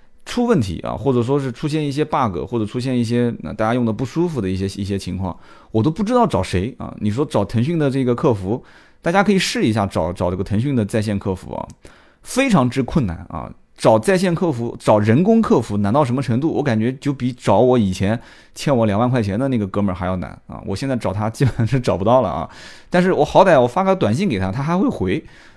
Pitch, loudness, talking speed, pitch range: 120 Hz, -19 LUFS, 350 characters per minute, 100-145 Hz